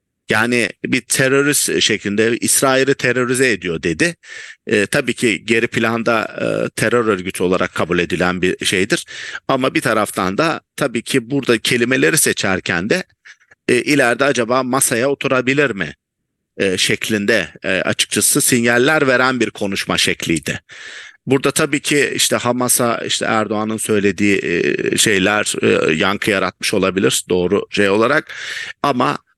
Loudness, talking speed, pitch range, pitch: -16 LUFS, 130 wpm, 110-135 Hz, 120 Hz